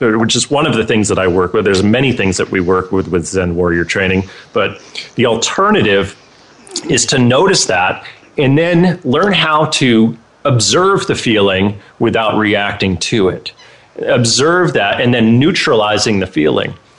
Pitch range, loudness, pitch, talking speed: 95-135 Hz, -12 LUFS, 110 Hz, 165 wpm